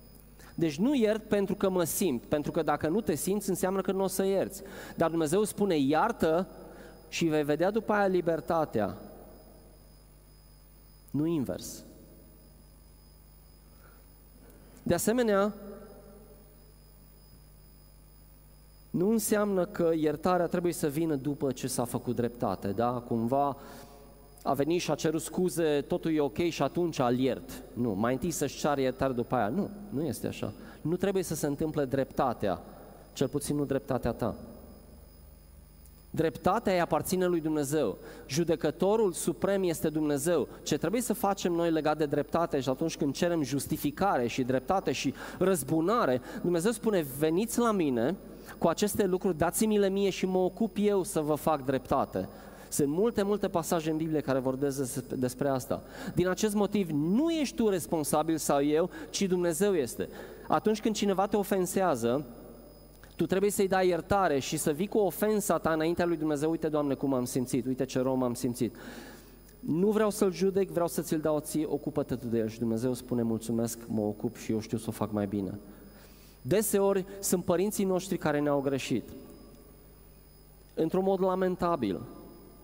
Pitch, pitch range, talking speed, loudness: 160 Hz, 135-190 Hz, 155 wpm, -30 LUFS